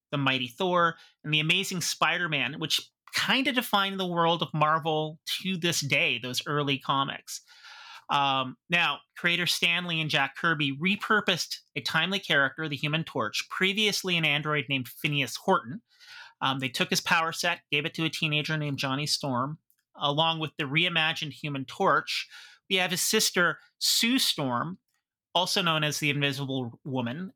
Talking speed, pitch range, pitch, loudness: 160 wpm, 140-180 Hz, 155 Hz, -26 LUFS